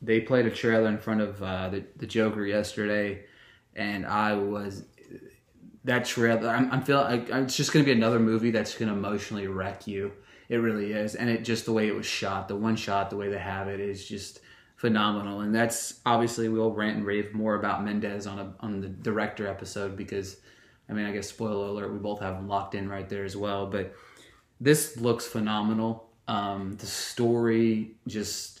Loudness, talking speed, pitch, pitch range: -28 LUFS, 205 wpm, 105 Hz, 100-115 Hz